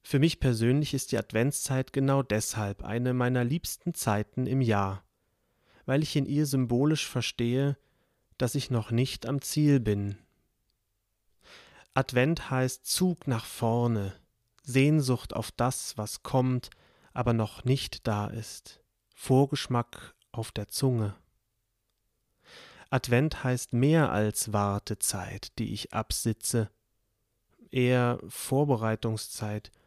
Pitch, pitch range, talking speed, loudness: 120 Hz, 110-135 Hz, 115 wpm, -29 LUFS